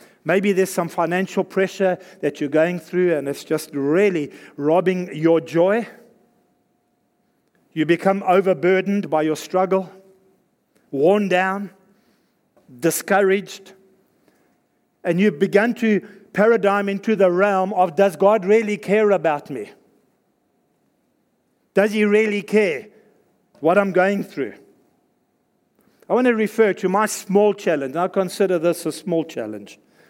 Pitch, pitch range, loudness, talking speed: 190 Hz, 175-205 Hz, -19 LUFS, 125 wpm